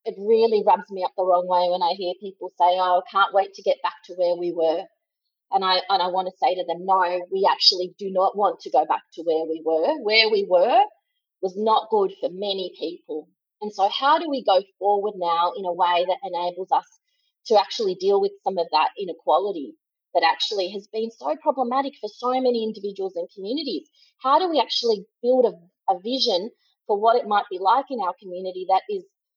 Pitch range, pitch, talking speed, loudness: 180-270 Hz, 205 Hz, 220 wpm, -22 LUFS